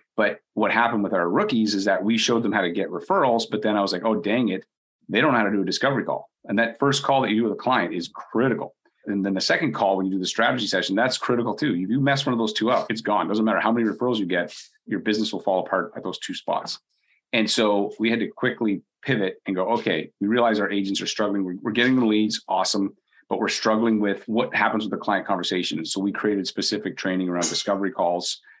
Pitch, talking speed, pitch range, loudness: 105 Hz, 260 wpm, 100-115 Hz, -23 LUFS